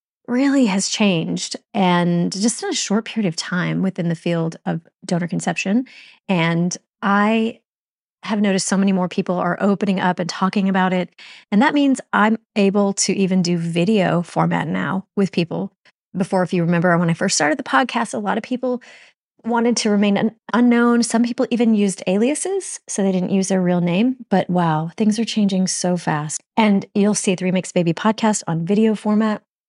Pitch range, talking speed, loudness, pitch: 180-220 Hz, 190 wpm, -19 LUFS, 195 Hz